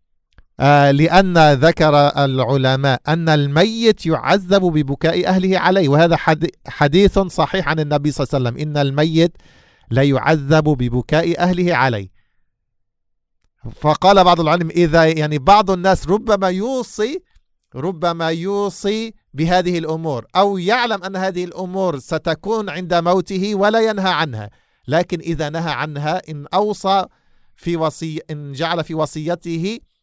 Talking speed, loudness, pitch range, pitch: 125 wpm, -16 LUFS, 150-185 Hz, 165 Hz